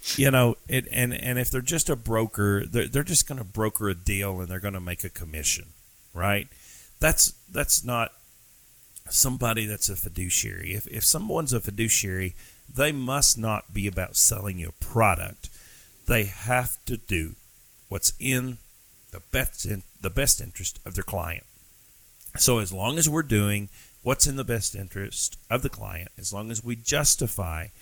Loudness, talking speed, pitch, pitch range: -25 LUFS, 175 wpm, 110 Hz, 95-125 Hz